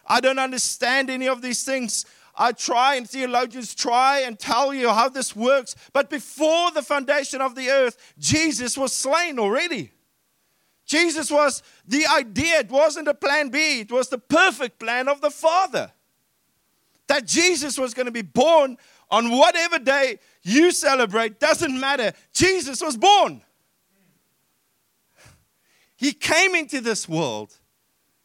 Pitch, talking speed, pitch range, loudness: 270 Hz, 145 wpm, 245-305 Hz, -20 LUFS